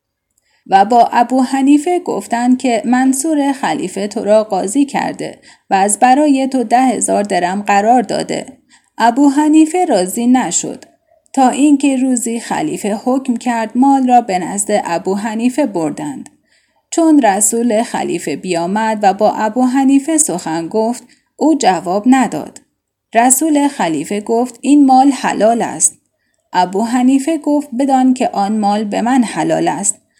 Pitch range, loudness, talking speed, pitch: 215-280 Hz, -13 LUFS, 135 wpm, 250 Hz